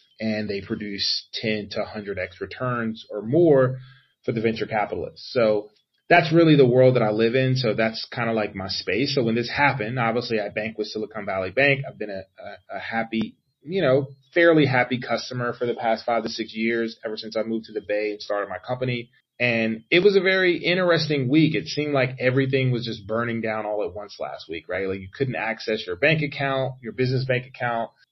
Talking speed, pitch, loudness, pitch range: 220 wpm, 120 Hz, -23 LUFS, 110-135 Hz